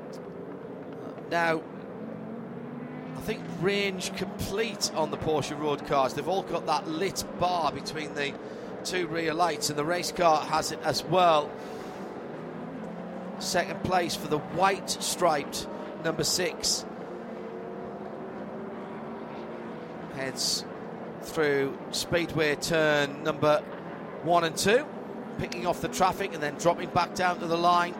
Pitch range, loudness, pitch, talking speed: 155-195 Hz, -29 LUFS, 170 Hz, 120 wpm